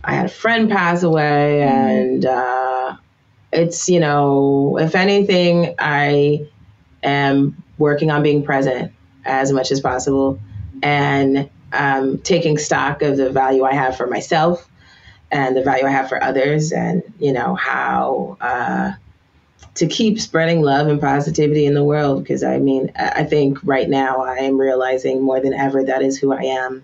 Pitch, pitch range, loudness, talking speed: 140 Hz, 130-150 Hz, -17 LUFS, 165 wpm